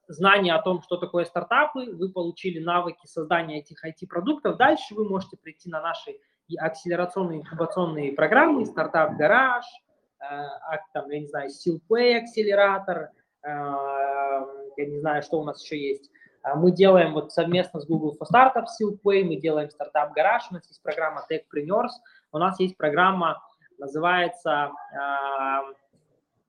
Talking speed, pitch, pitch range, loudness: 130 wpm, 170 Hz, 150-195 Hz, -24 LUFS